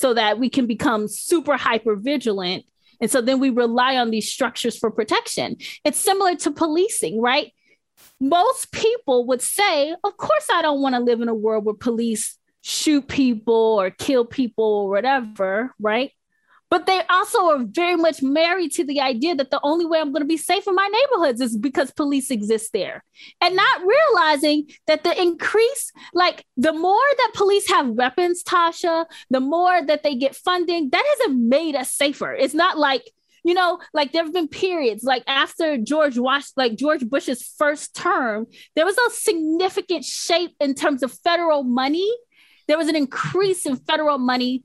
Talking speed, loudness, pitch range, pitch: 180 wpm, -20 LUFS, 255-345 Hz, 300 Hz